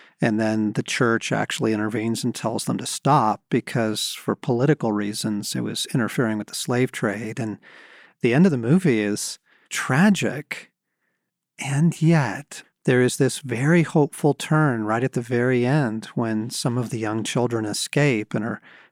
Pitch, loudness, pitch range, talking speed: 120 Hz, -22 LUFS, 110-145 Hz, 165 wpm